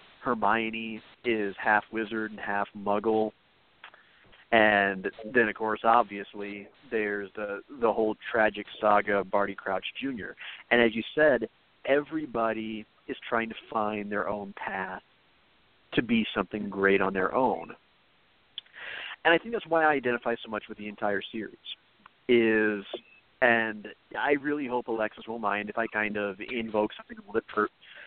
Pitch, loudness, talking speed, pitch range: 110 Hz, -28 LUFS, 150 wpm, 105-115 Hz